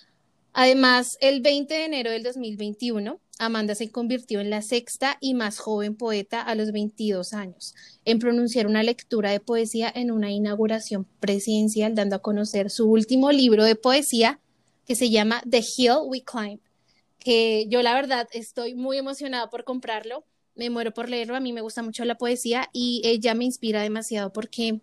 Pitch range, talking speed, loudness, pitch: 215-245 Hz, 175 wpm, -24 LUFS, 230 Hz